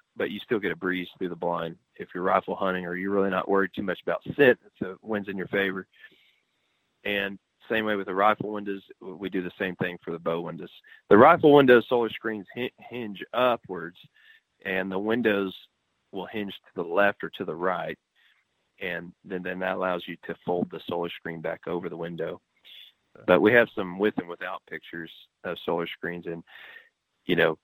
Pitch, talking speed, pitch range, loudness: 95 Hz, 200 wpm, 90-105 Hz, -26 LUFS